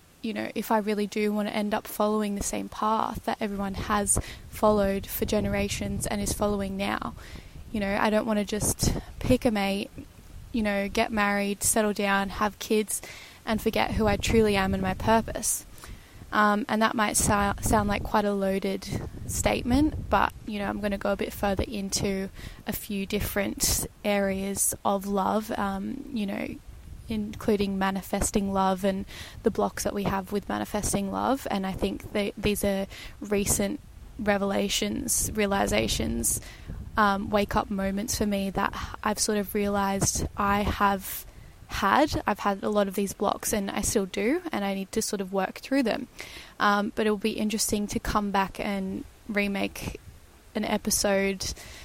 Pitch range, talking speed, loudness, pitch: 195-215 Hz, 175 wpm, -27 LUFS, 205 Hz